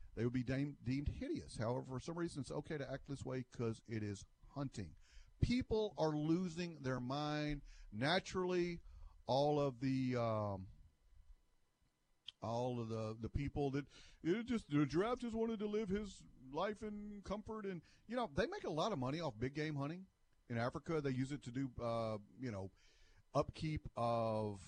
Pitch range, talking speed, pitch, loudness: 115-170 Hz, 180 wpm, 135 Hz, -42 LUFS